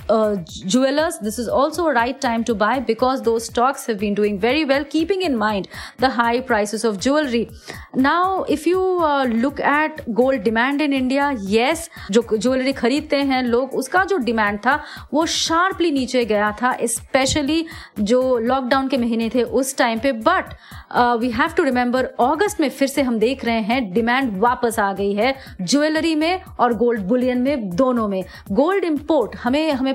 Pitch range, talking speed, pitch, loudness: 230-290 Hz, 165 wpm, 255 Hz, -19 LUFS